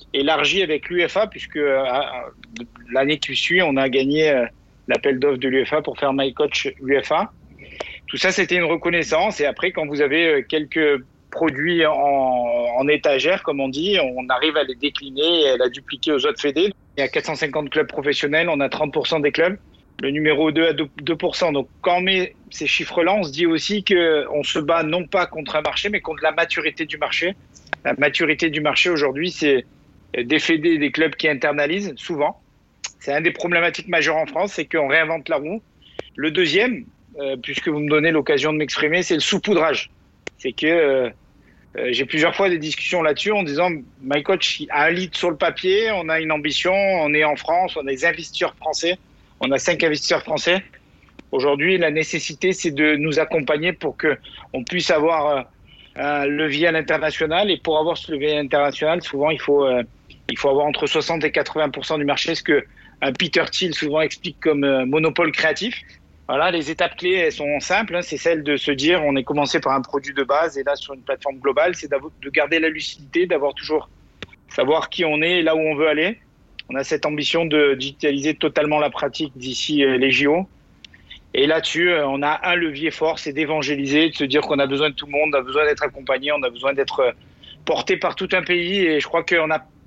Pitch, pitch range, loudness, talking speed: 155 Hz, 145-170 Hz, -20 LUFS, 205 wpm